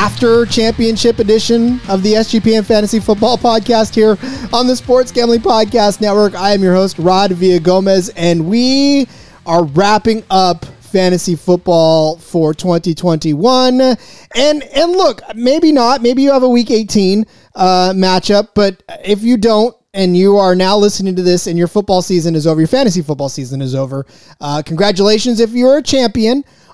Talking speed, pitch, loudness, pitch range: 170 wpm, 210 Hz, -12 LUFS, 180-235 Hz